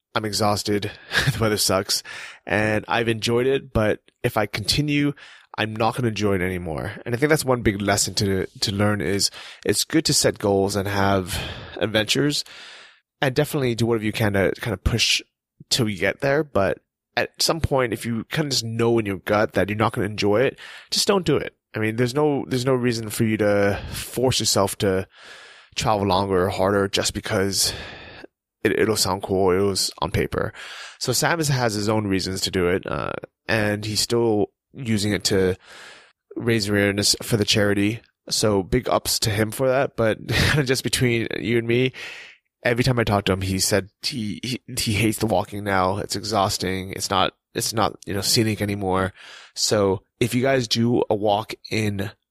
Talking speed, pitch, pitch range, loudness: 195 wpm, 110 Hz, 100-120 Hz, -22 LUFS